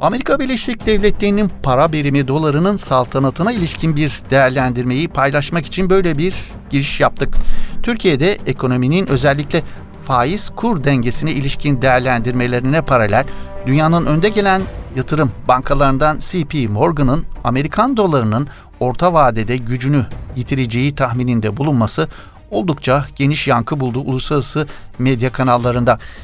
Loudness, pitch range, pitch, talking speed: -16 LUFS, 125-160 Hz, 140 Hz, 105 wpm